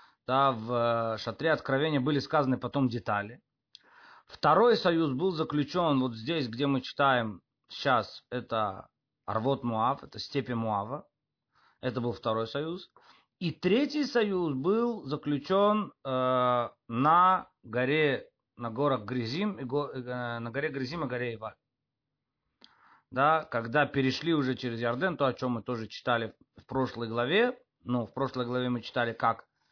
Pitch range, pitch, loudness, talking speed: 120-155 Hz, 130 Hz, -29 LUFS, 145 wpm